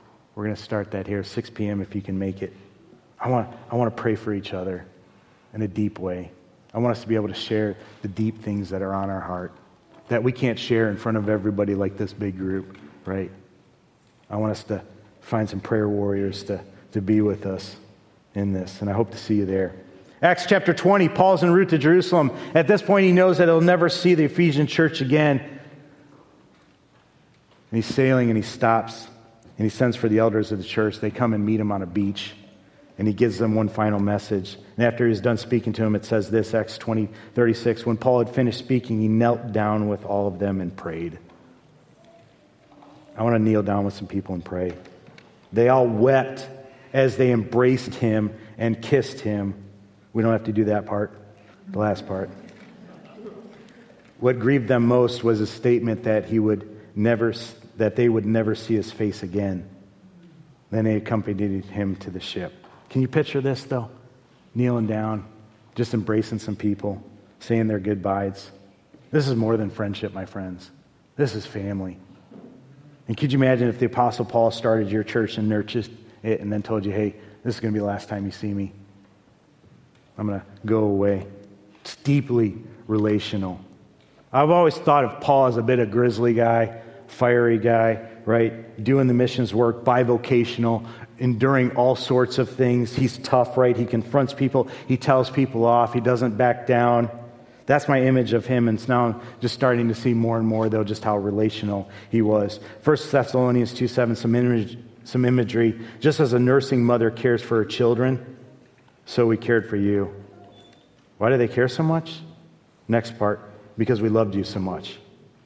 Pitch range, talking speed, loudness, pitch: 105-125 Hz, 190 wpm, -22 LUFS, 115 Hz